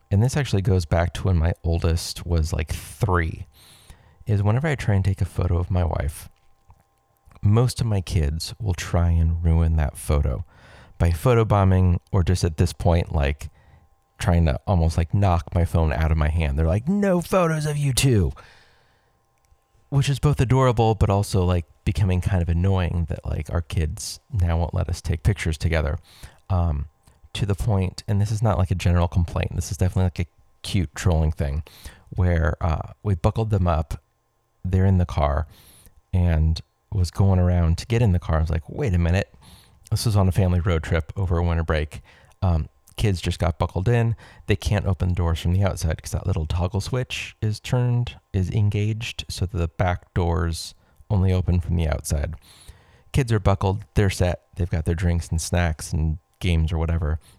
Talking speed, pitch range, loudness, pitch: 195 wpm, 85-100 Hz, -23 LUFS, 90 Hz